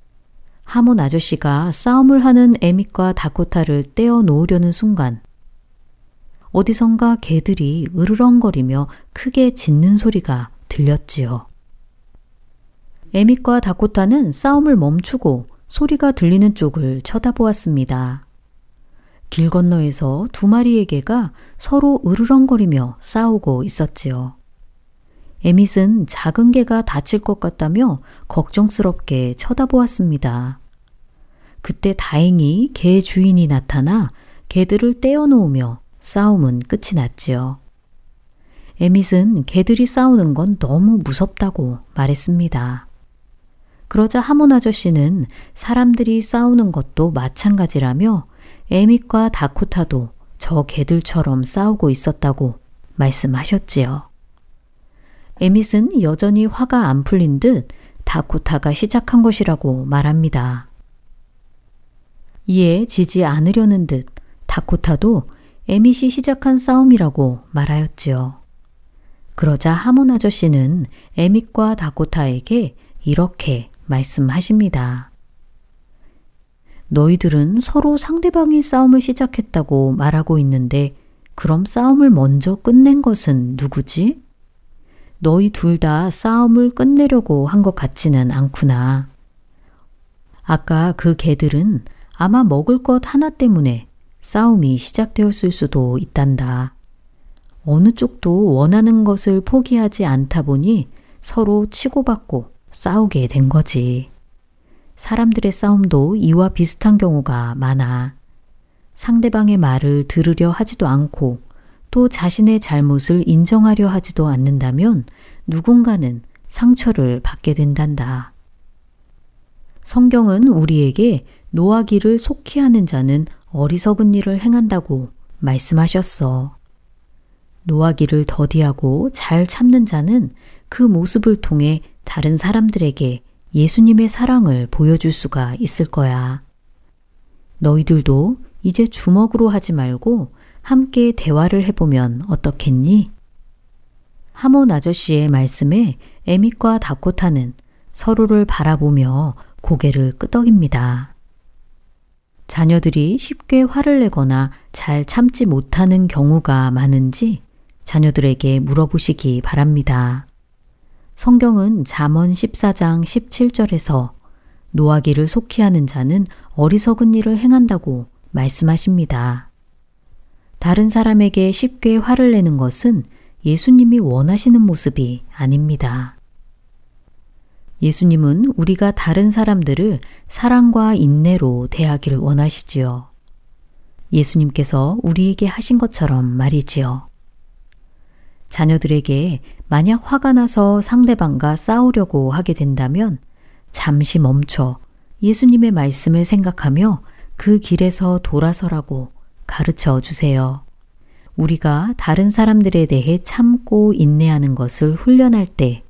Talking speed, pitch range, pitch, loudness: 245 characters per minute, 135-215 Hz, 165 Hz, -15 LUFS